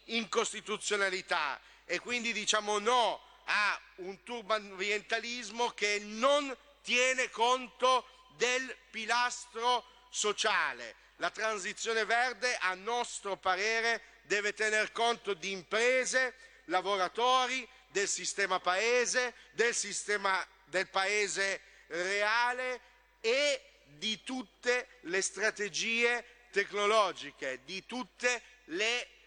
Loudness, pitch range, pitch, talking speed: -32 LUFS, 200-245 Hz, 225 Hz, 90 wpm